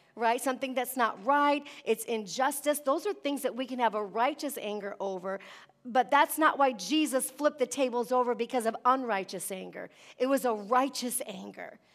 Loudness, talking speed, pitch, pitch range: -30 LUFS, 180 wpm, 255 Hz, 225-275 Hz